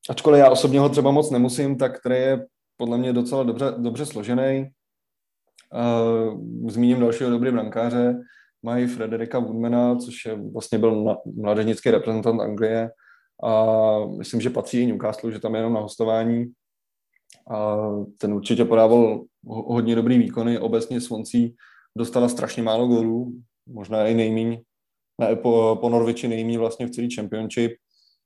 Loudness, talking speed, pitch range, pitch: -22 LUFS, 140 wpm, 110-120 Hz, 115 Hz